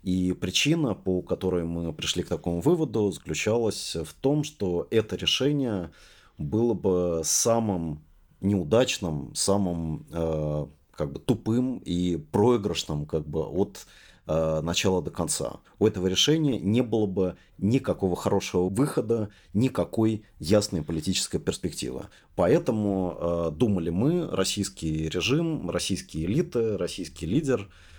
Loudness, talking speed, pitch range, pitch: -27 LUFS, 120 wpm, 85-115 Hz, 95 Hz